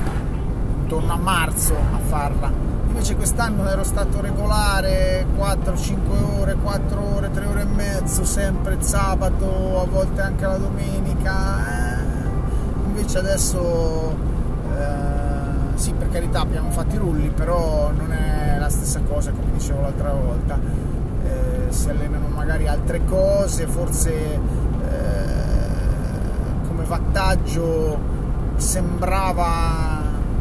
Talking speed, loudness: 110 wpm, -22 LUFS